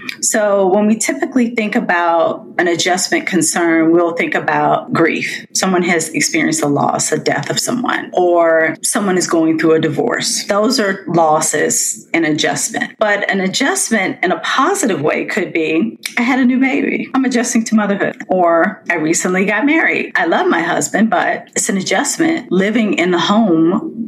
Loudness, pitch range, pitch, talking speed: -14 LUFS, 170-235 Hz, 195 Hz, 170 wpm